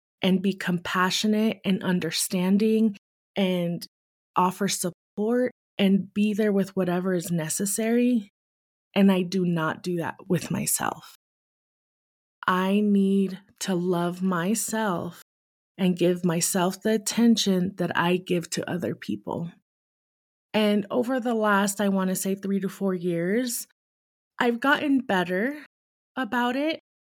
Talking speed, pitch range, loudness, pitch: 120 wpm, 180-215 Hz, -25 LUFS, 195 Hz